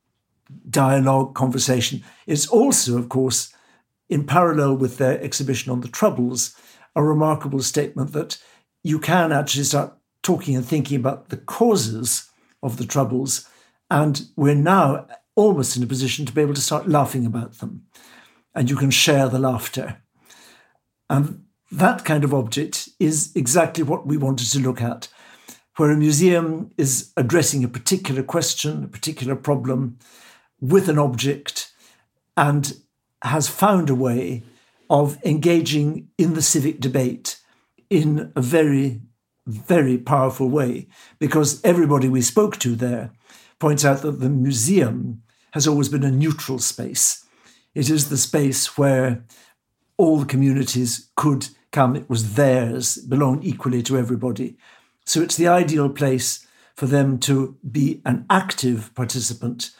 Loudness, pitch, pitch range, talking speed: -20 LUFS, 140 Hz, 130-155 Hz, 145 wpm